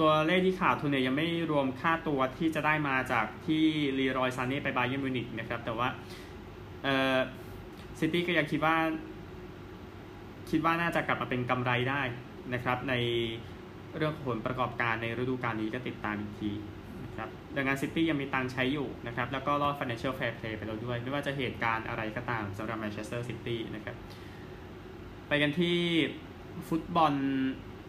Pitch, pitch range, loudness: 130 Hz, 115-150 Hz, -31 LUFS